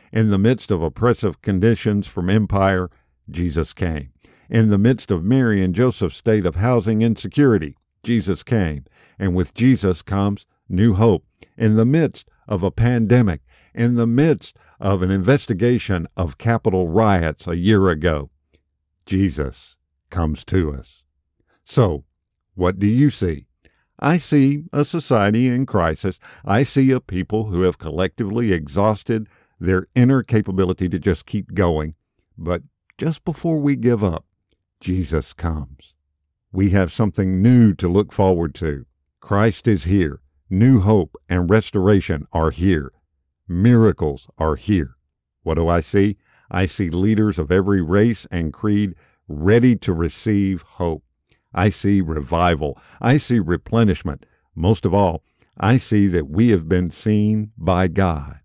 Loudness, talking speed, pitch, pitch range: -19 LUFS, 145 wpm, 95 Hz, 85-110 Hz